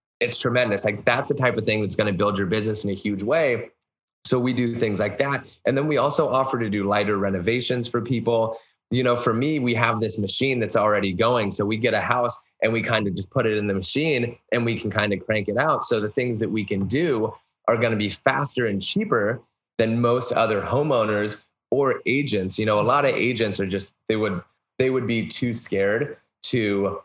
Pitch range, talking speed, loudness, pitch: 105-120 Hz, 235 wpm, -23 LUFS, 110 Hz